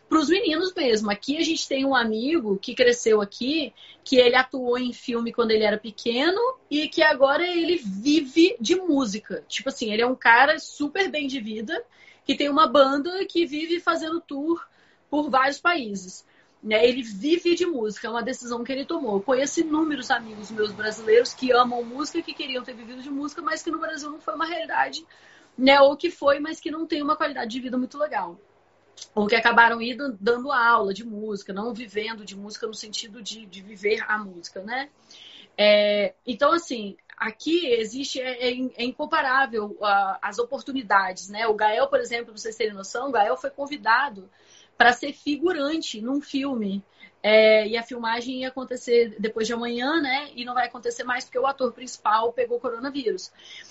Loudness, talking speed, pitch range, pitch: -23 LUFS, 185 wpm, 225-300 Hz, 255 Hz